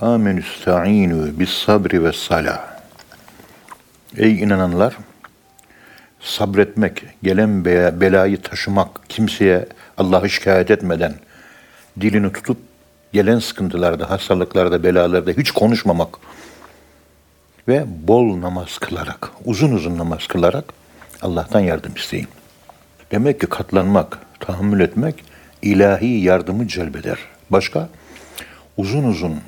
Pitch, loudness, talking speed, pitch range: 95 Hz, -17 LUFS, 95 wpm, 90-105 Hz